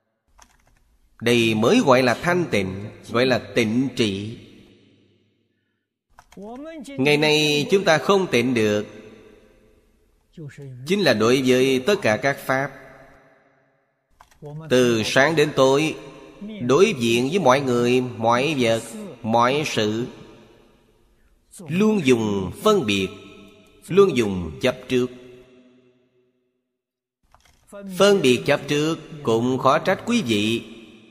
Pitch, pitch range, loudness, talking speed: 125 Hz, 110-145 Hz, -20 LUFS, 105 wpm